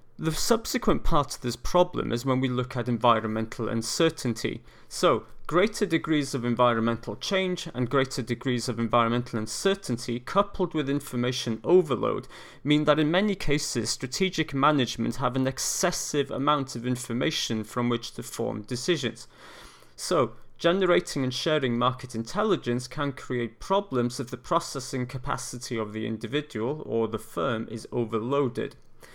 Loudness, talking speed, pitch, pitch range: -27 LUFS, 140 wpm, 125 Hz, 120-150 Hz